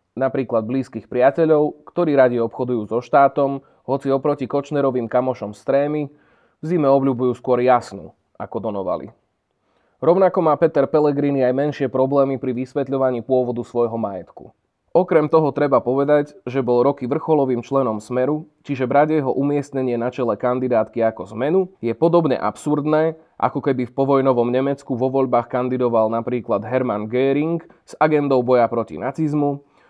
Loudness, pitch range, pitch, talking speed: -19 LUFS, 125-145 Hz, 135 Hz, 140 wpm